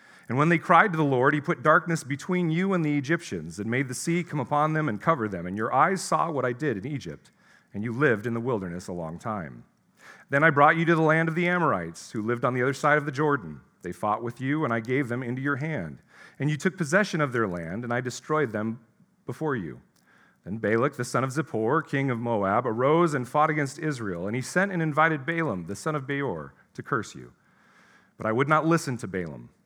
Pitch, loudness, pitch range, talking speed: 145 Hz, -26 LUFS, 115-160 Hz, 245 wpm